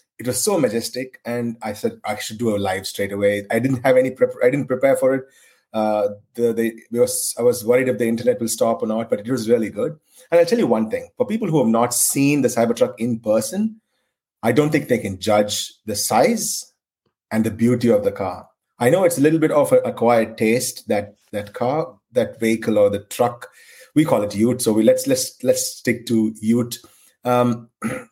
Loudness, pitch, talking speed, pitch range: -20 LUFS, 120 Hz, 225 wpm, 110-170 Hz